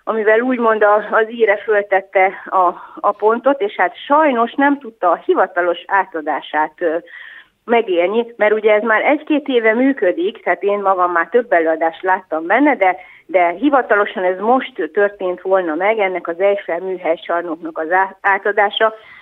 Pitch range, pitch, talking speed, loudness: 180-230 Hz, 200 Hz, 145 wpm, -16 LUFS